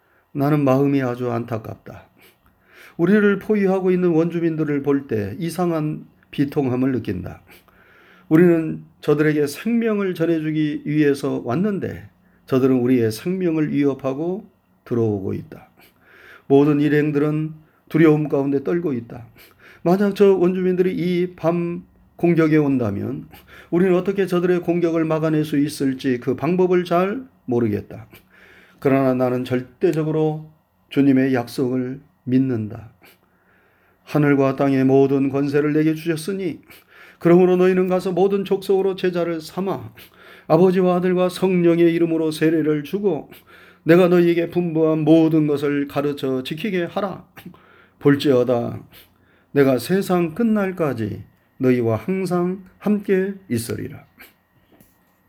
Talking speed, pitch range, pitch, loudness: 275 characters per minute, 130-180 Hz, 155 Hz, -19 LUFS